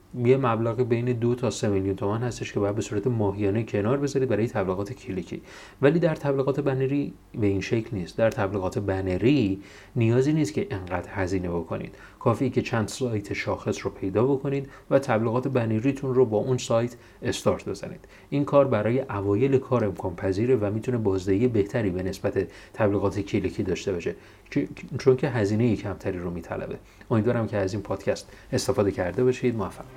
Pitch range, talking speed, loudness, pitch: 100-130 Hz, 170 wpm, -26 LUFS, 110 Hz